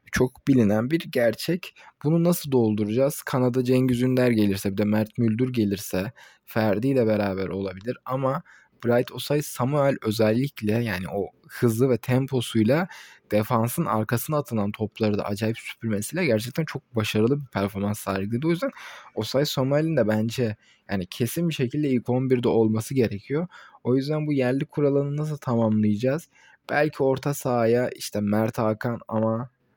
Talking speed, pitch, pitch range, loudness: 145 wpm, 125 Hz, 110-135 Hz, -25 LUFS